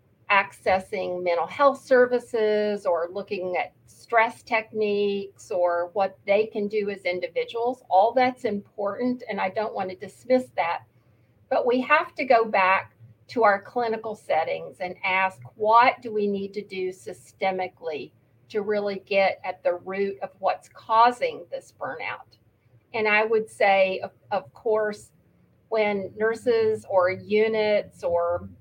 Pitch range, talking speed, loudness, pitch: 185-225 Hz, 145 wpm, -24 LUFS, 205 Hz